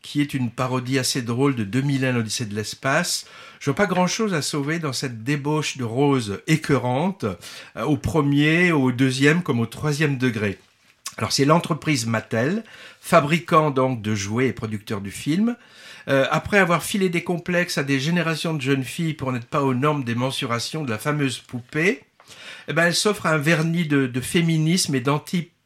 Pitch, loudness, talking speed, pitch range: 145 Hz, -22 LUFS, 180 wpm, 130-165 Hz